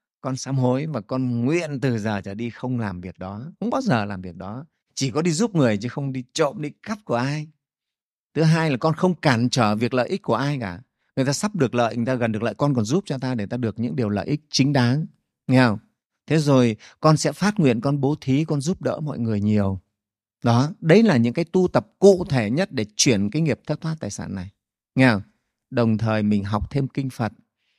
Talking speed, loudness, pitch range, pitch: 250 wpm, -22 LUFS, 115-150 Hz, 130 Hz